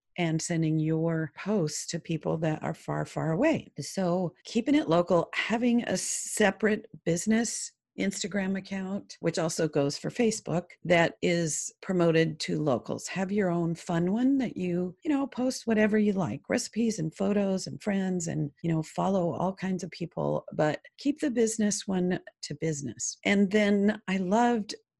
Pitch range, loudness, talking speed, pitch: 160-210 Hz, -29 LUFS, 165 wpm, 180 Hz